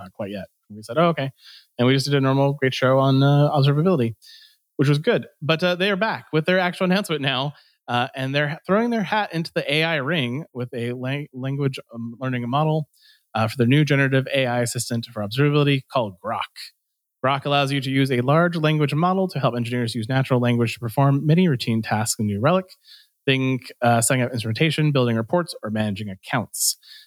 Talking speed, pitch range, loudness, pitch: 200 wpm, 125-160 Hz, -21 LUFS, 140 Hz